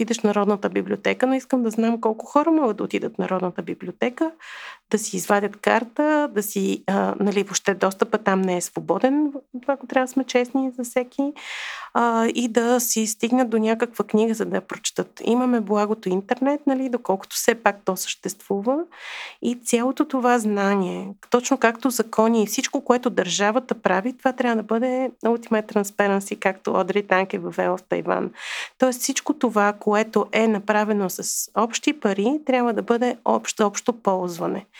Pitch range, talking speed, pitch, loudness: 205-255 Hz, 170 wpm, 225 Hz, -22 LUFS